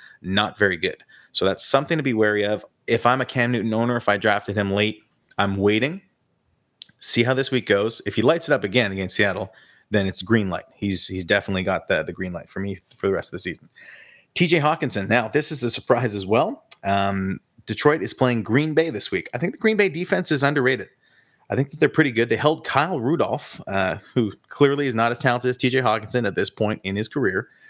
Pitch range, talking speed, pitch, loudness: 100-135 Hz, 230 wpm, 115 Hz, -22 LUFS